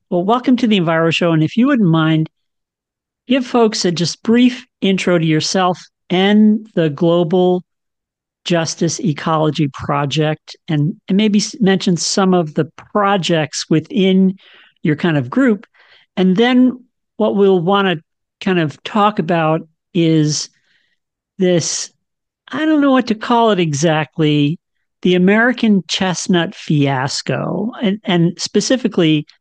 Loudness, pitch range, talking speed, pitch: -15 LUFS, 160-210 Hz, 135 wpm, 180 Hz